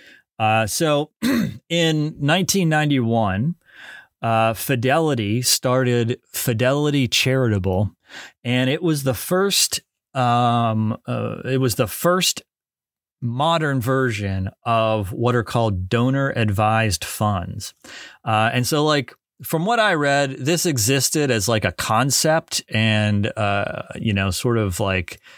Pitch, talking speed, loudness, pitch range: 125 Hz, 120 wpm, -20 LUFS, 110-150 Hz